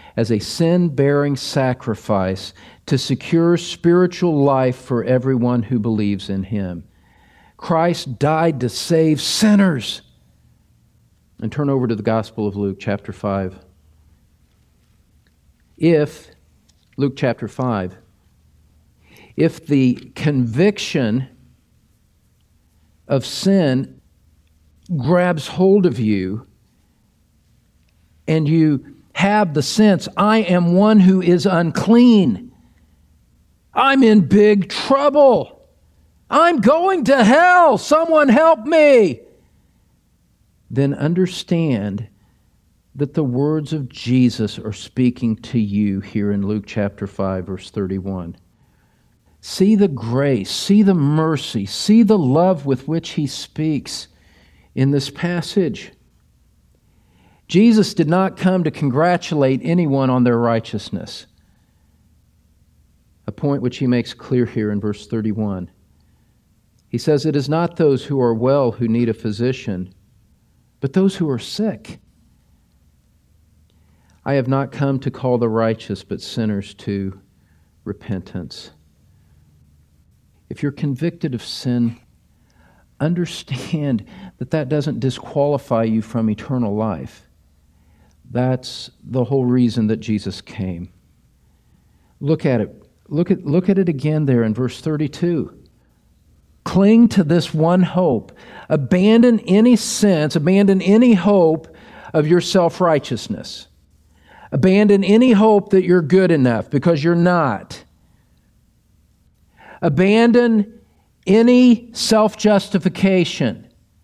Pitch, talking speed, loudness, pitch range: 130 Hz, 110 wpm, -17 LUFS, 105-170 Hz